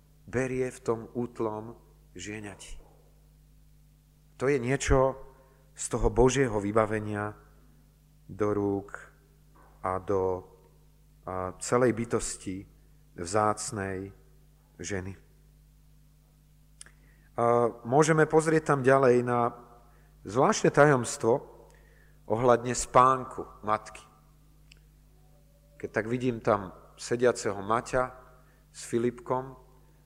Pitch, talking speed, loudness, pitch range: 120 Hz, 80 wpm, -28 LUFS, 105-150 Hz